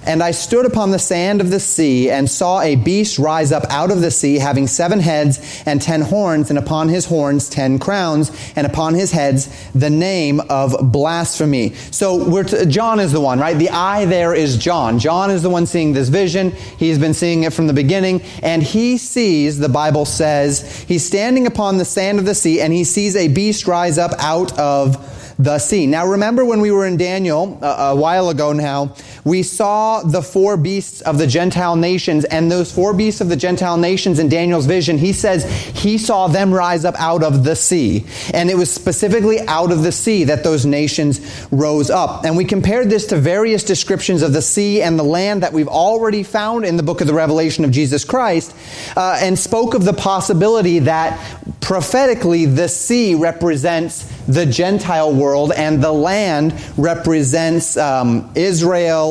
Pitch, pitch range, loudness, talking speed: 165 Hz, 150-190 Hz, -15 LUFS, 195 wpm